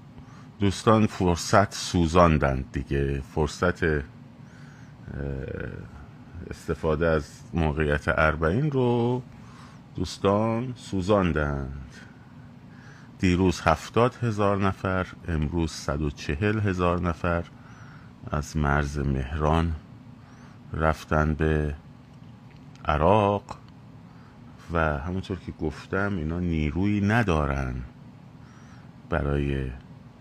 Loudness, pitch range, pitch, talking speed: -26 LUFS, 75-115 Hz, 85 Hz, 70 wpm